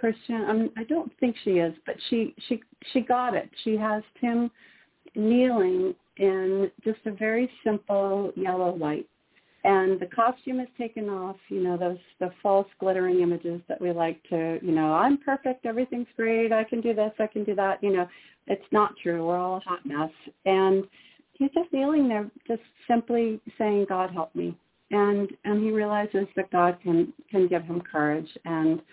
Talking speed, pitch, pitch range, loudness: 185 wpm, 210 Hz, 180-235 Hz, -27 LUFS